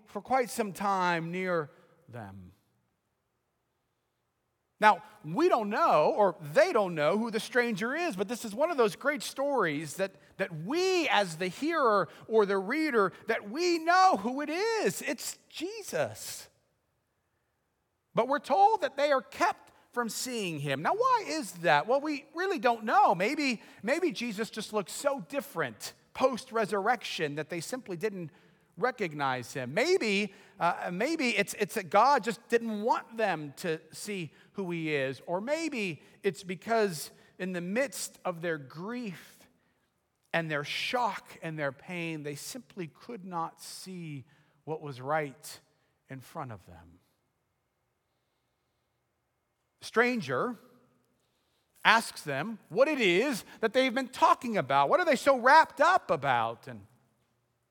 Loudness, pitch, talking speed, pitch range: -29 LUFS, 205 Hz, 145 wpm, 160-255 Hz